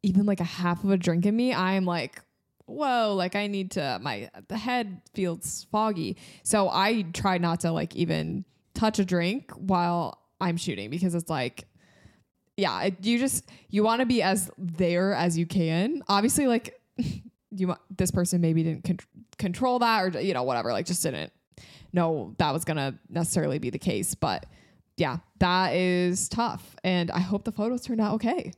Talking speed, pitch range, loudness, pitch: 185 wpm, 175-210 Hz, -27 LUFS, 185 Hz